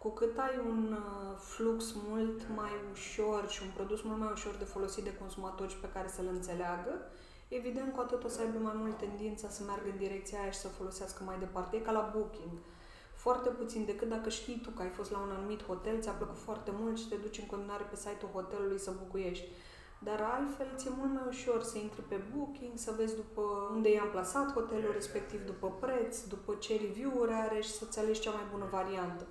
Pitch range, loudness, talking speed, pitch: 195-225 Hz, -38 LUFS, 210 wpm, 210 Hz